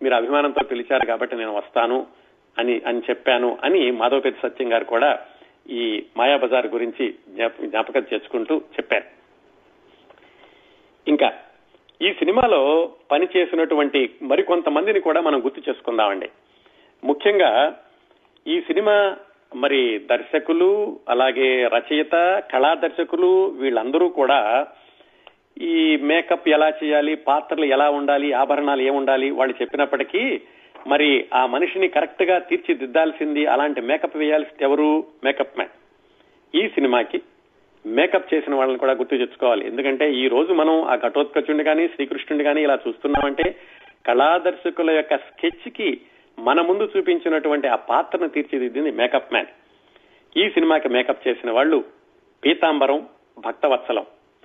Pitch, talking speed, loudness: 185 Hz, 110 wpm, -20 LUFS